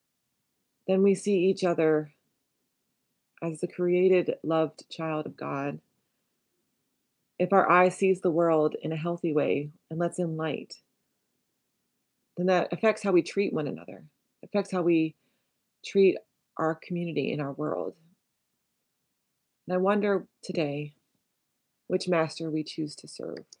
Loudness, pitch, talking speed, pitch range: -28 LUFS, 170 Hz, 135 wpm, 160-185 Hz